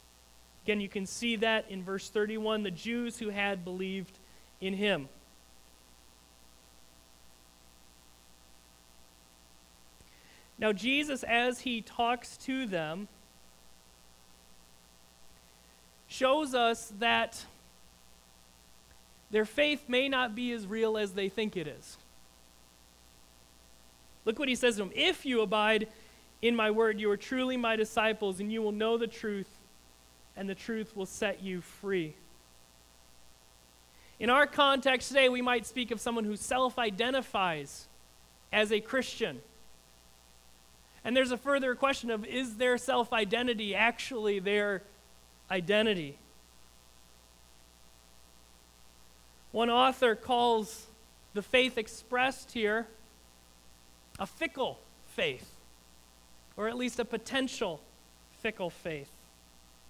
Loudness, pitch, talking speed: -31 LUFS, 190 Hz, 110 wpm